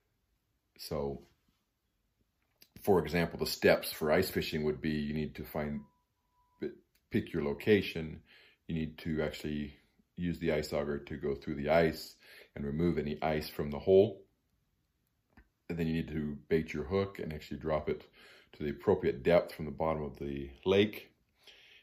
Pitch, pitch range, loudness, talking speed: 75 Hz, 75-85 Hz, -33 LUFS, 160 wpm